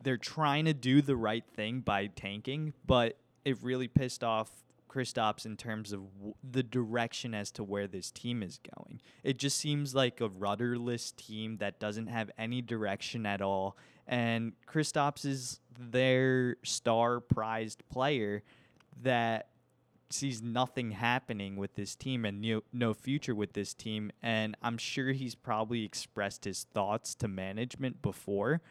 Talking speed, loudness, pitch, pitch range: 155 wpm, -34 LUFS, 120 Hz, 110-130 Hz